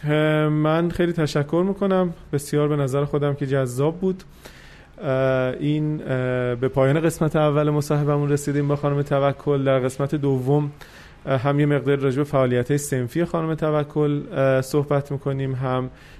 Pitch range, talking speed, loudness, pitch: 135-150 Hz, 135 wpm, -22 LUFS, 145 Hz